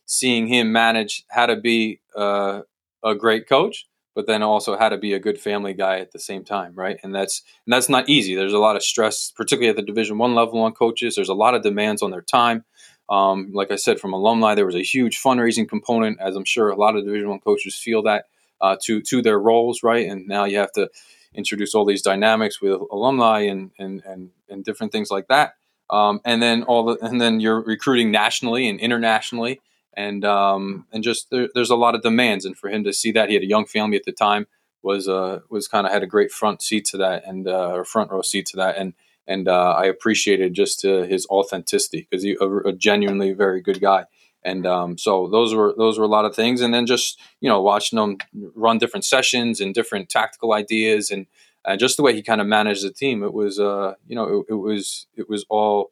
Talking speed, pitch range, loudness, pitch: 235 wpm, 100-115 Hz, -20 LUFS, 105 Hz